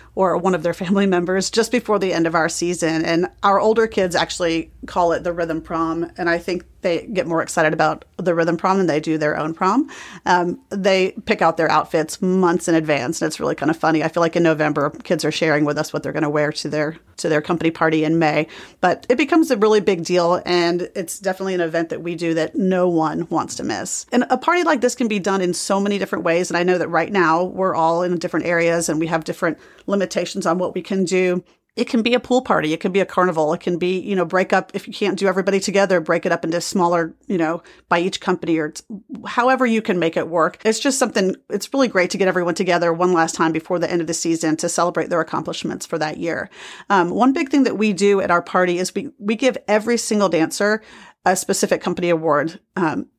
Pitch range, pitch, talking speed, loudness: 165-200 Hz, 180 Hz, 250 wpm, -19 LUFS